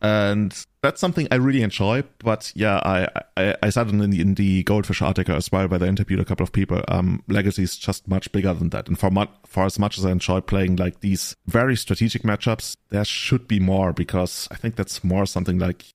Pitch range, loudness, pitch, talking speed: 95-105 Hz, -22 LUFS, 100 Hz, 230 wpm